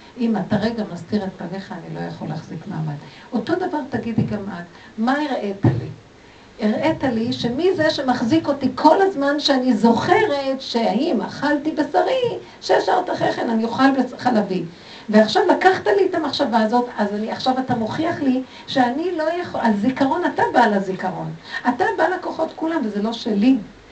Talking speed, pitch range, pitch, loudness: 165 wpm, 210-300 Hz, 245 Hz, -20 LUFS